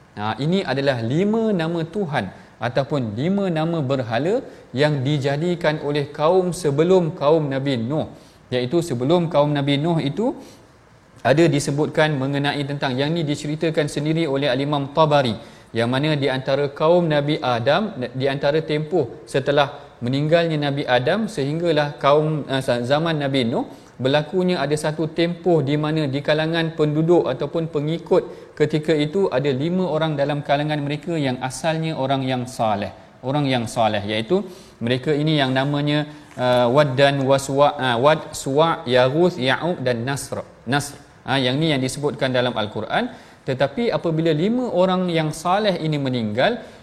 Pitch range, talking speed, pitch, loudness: 135-160 Hz, 145 wpm, 145 Hz, -21 LUFS